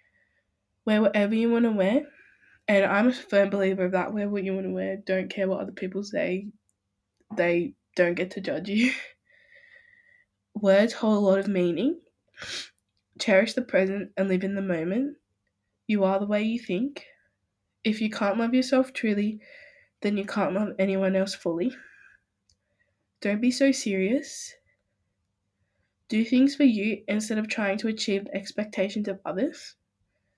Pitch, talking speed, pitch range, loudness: 205 Hz, 160 wpm, 190-250 Hz, -26 LUFS